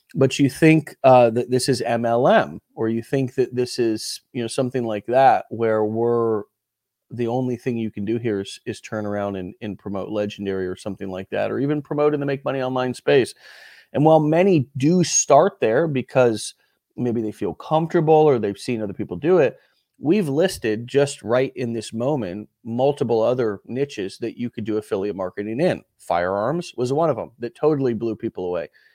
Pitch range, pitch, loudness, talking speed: 110-140 Hz, 120 Hz, -21 LUFS, 195 wpm